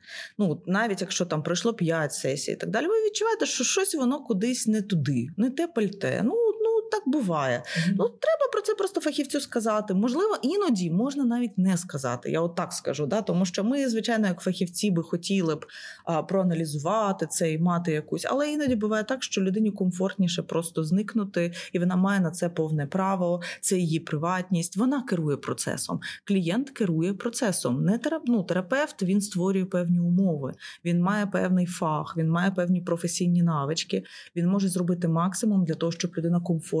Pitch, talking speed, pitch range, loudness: 190 Hz, 175 wpm, 170-230 Hz, -26 LUFS